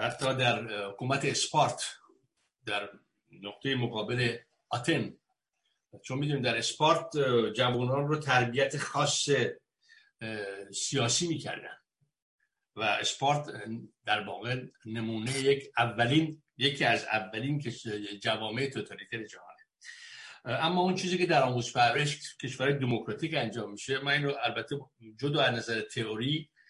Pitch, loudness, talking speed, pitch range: 130 Hz, -30 LUFS, 115 wpm, 115-145 Hz